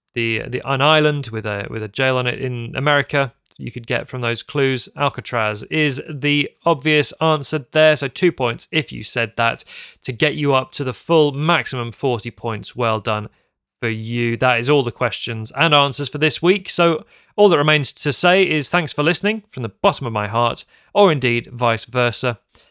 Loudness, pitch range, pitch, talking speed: -18 LUFS, 120-155 Hz, 135 Hz, 200 wpm